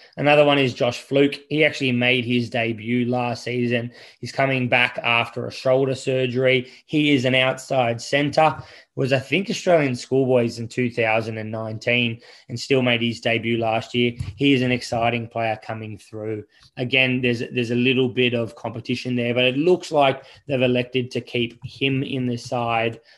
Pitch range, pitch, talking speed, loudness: 115-135 Hz, 125 Hz, 180 wpm, -21 LUFS